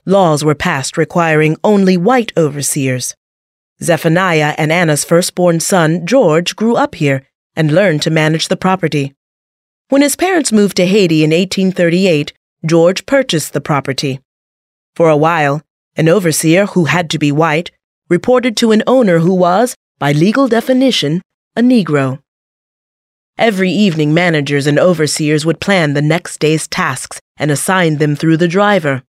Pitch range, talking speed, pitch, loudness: 150-190 Hz, 150 wpm, 165 Hz, -12 LUFS